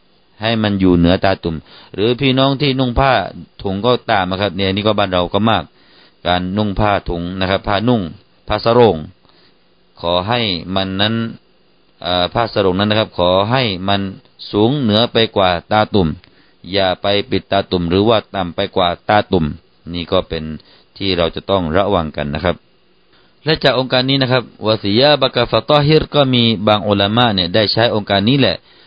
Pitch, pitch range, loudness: 100 Hz, 90-115 Hz, -15 LUFS